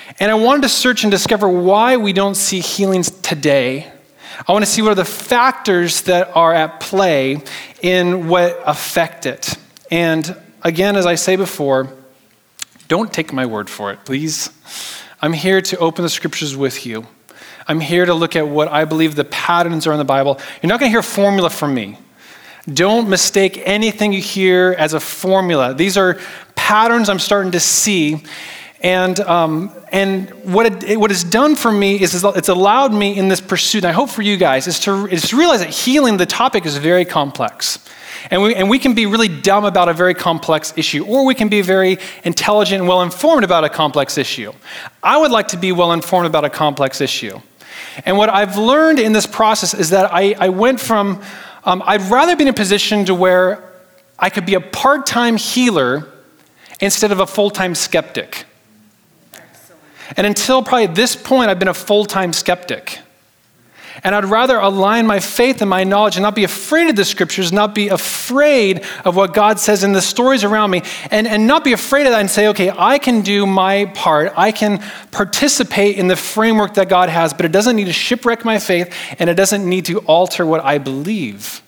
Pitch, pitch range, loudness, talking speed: 190 Hz, 170-210 Hz, -14 LUFS, 200 wpm